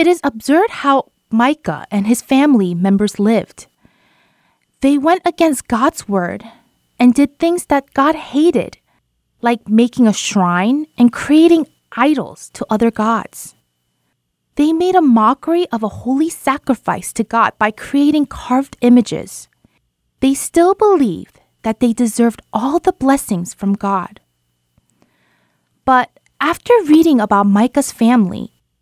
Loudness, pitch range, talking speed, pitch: -14 LUFS, 220-295 Hz, 130 wpm, 245 Hz